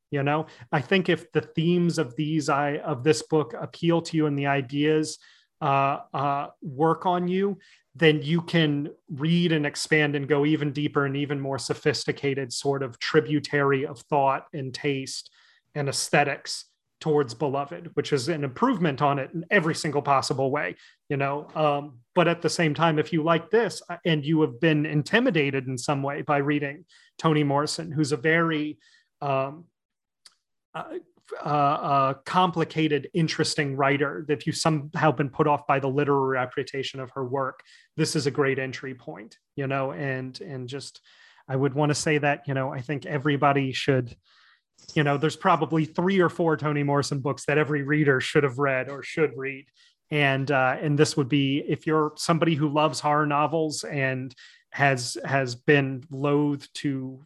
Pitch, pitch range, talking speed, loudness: 150 Hz, 140-155 Hz, 175 wpm, -25 LUFS